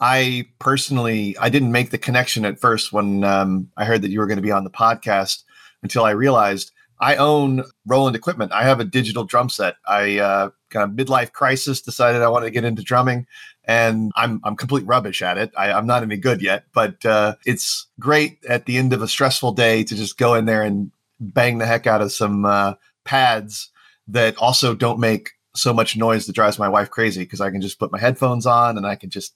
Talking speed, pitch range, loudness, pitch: 225 wpm, 105-125 Hz, -18 LUFS, 115 Hz